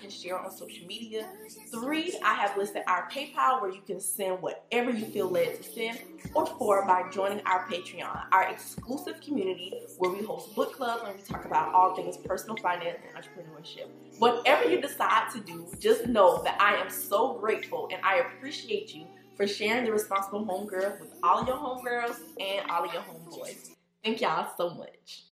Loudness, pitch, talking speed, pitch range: -29 LUFS, 220 Hz, 185 wpm, 185-255 Hz